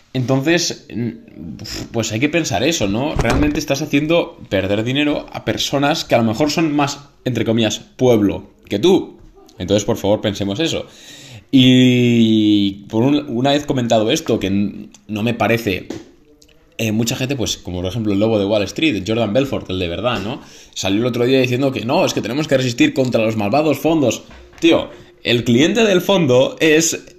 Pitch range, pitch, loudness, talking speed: 110-145 Hz, 120 Hz, -17 LUFS, 180 wpm